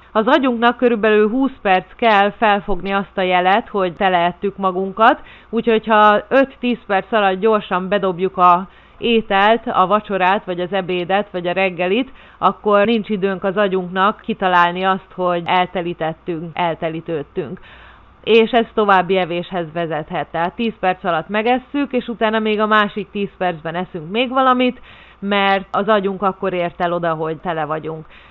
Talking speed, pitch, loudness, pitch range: 150 wpm, 195 Hz, -17 LUFS, 180-215 Hz